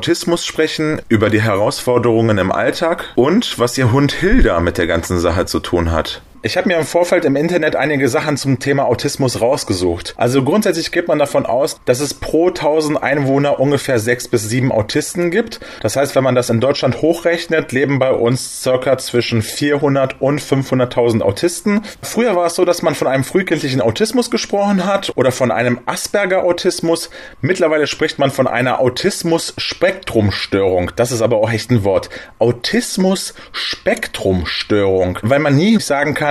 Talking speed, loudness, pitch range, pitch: 170 wpm, -15 LUFS, 120-165 Hz, 140 Hz